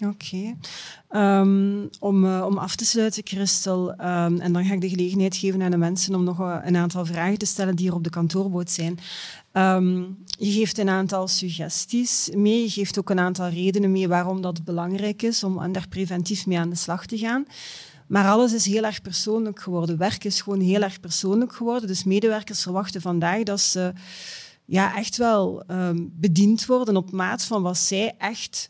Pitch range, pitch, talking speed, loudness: 180-205 Hz, 190 Hz, 190 wpm, -23 LUFS